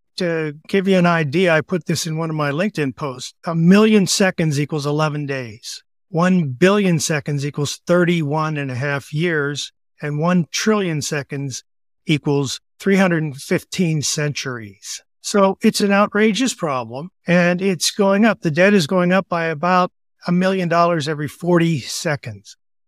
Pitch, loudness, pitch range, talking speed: 165 Hz, -18 LUFS, 145-185 Hz, 150 wpm